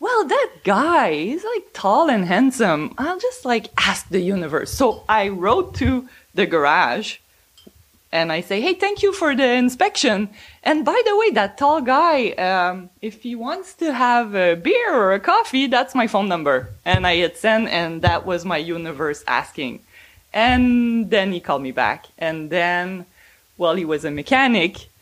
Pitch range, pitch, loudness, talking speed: 175-295 Hz, 220 Hz, -19 LUFS, 175 wpm